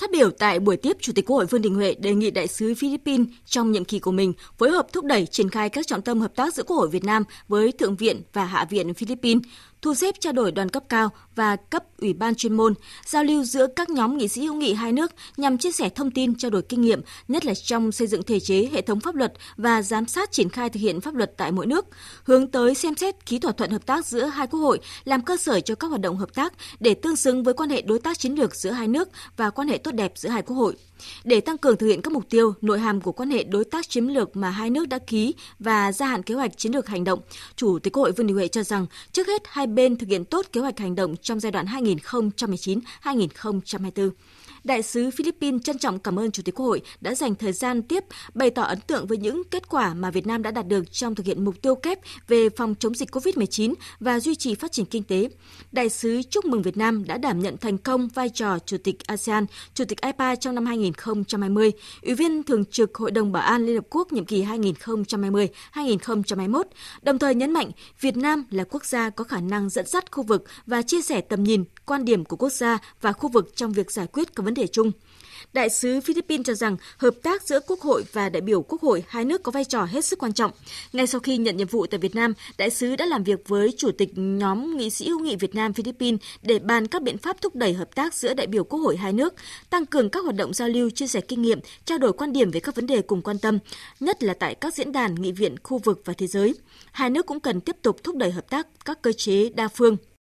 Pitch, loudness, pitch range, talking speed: 230 Hz, -24 LUFS, 205-270 Hz, 260 wpm